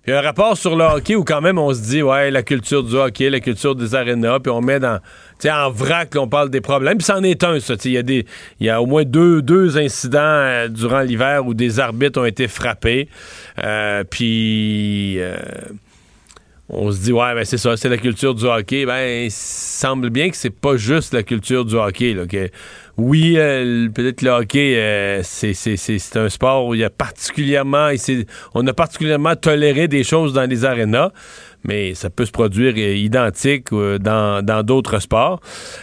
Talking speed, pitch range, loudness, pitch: 210 wpm, 115-140 Hz, -17 LUFS, 125 Hz